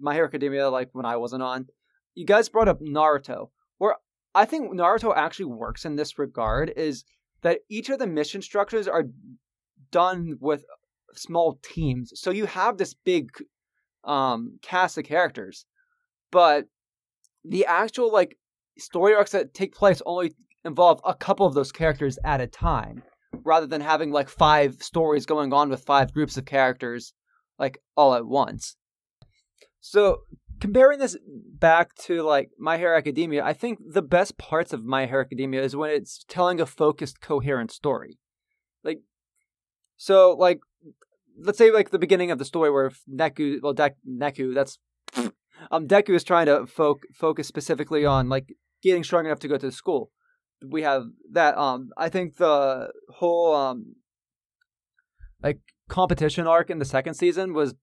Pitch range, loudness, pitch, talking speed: 140-190 Hz, -23 LUFS, 160 Hz, 160 wpm